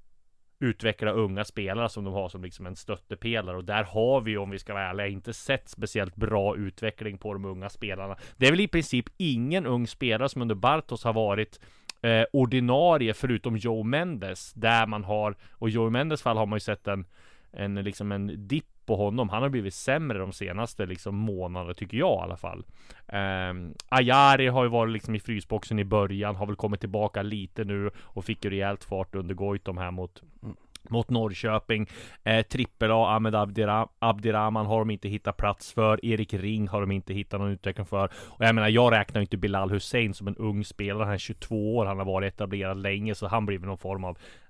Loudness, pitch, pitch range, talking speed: -28 LUFS, 105 Hz, 100-115 Hz, 200 wpm